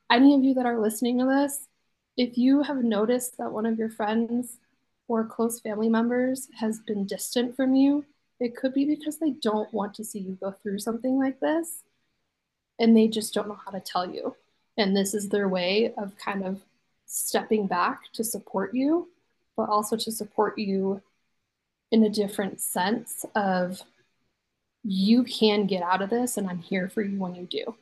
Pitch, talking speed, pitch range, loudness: 225 Hz, 190 wpm, 205-245 Hz, -26 LUFS